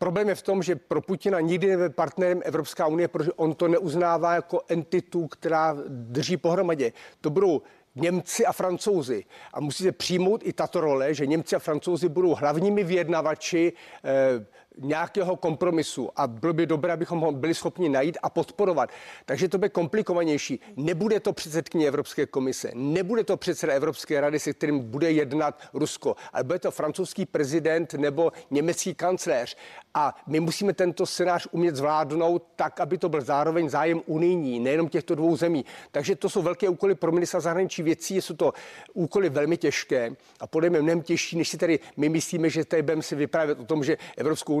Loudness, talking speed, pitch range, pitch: -26 LUFS, 175 wpm, 155-180 Hz, 170 Hz